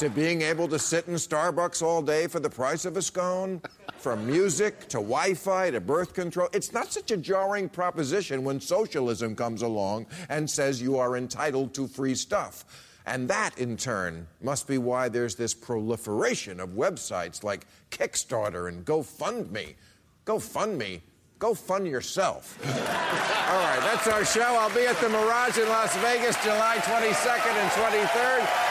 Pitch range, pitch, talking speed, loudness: 125-205 Hz, 165 Hz, 165 wpm, -27 LUFS